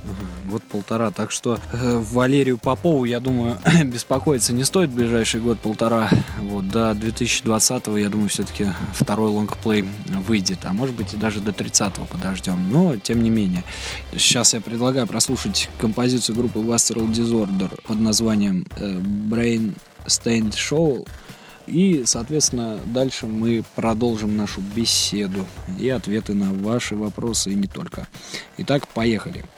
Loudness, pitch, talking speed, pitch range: -21 LUFS, 110 Hz, 130 wpm, 100-120 Hz